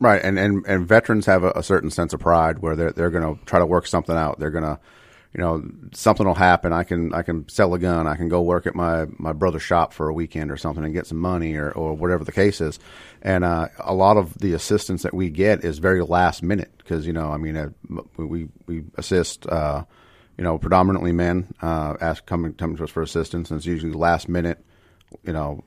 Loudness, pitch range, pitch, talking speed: -22 LUFS, 80-90 Hz, 85 Hz, 240 wpm